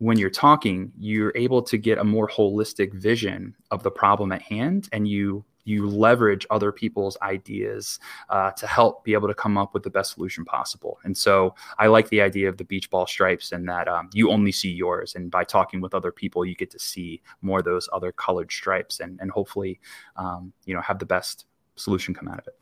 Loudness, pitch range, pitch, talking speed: -23 LUFS, 95-110 Hz, 100 Hz, 225 wpm